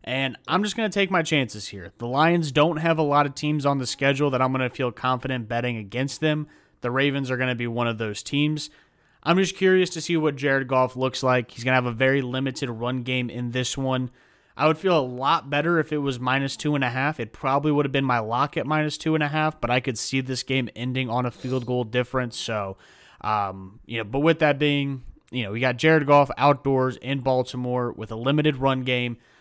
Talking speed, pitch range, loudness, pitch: 250 wpm, 125-150 Hz, -24 LUFS, 130 Hz